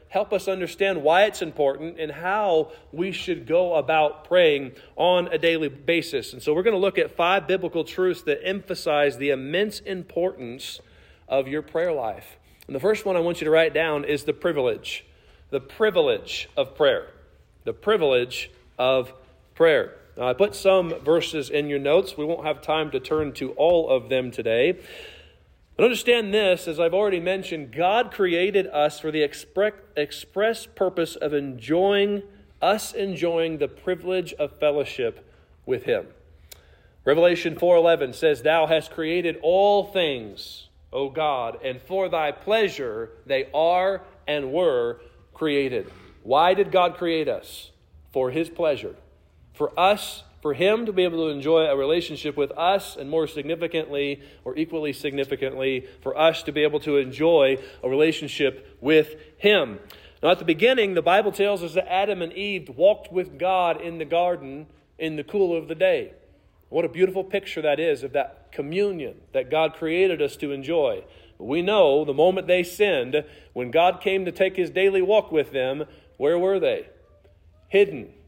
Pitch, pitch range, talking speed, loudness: 170 Hz, 150-200 Hz, 165 wpm, -23 LUFS